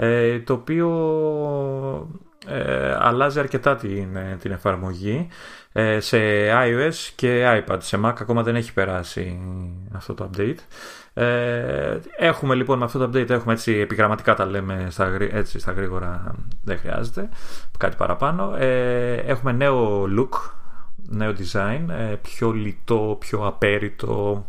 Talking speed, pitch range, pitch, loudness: 125 wpm, 100-130 Hz, 110 Hz, -22 LUFS